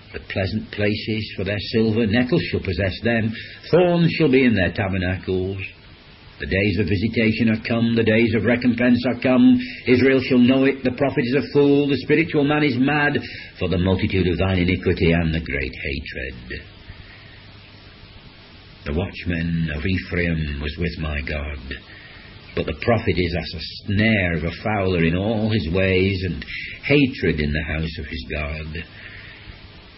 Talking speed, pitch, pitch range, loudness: 165 wpm, 100 Hz, 85-115 Hz, -20 LUFS